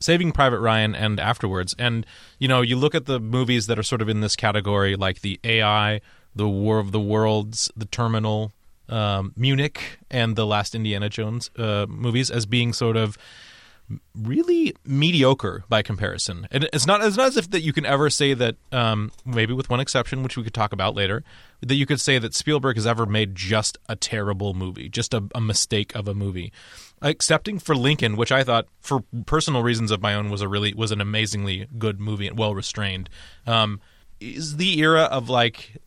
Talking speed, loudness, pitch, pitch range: 200 wpm, -22 LUFS, 110 Hz, 105-130 Hz